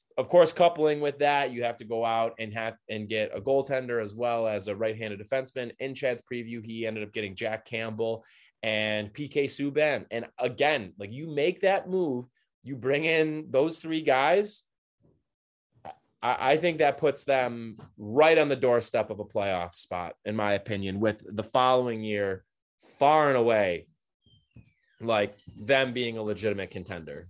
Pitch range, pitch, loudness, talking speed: 110-140 Hz, 120 Hz, -27 LUFS, 170 wpm